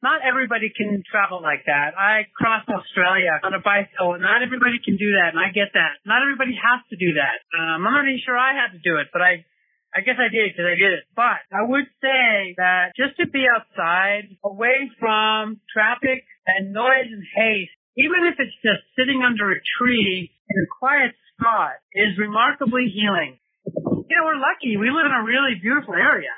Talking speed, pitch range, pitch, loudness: 205 wpm, 195-255 Hz, 215 Hz, -19 LUFS